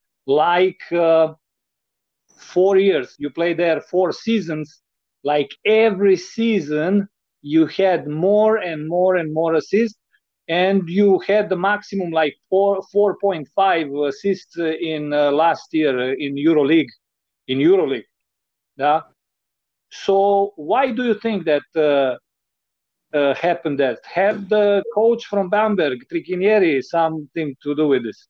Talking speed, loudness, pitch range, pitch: 125 wpm, -19 LUFS, 155-200 Hz, 180 Hz